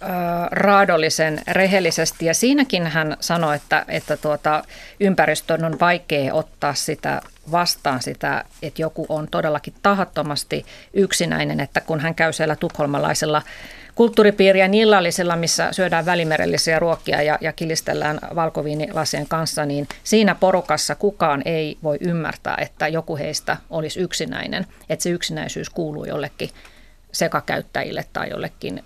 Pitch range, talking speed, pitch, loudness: 150-180 Hz, 125 wpm, 160 Hz, -20 LUFS